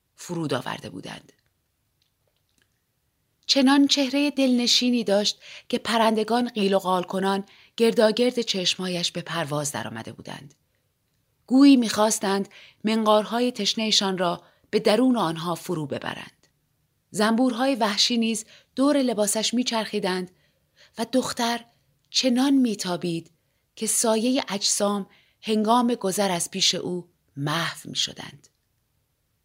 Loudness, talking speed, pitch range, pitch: -23 LUFS, 100 wpm, 175-235 Hz, 210 Hz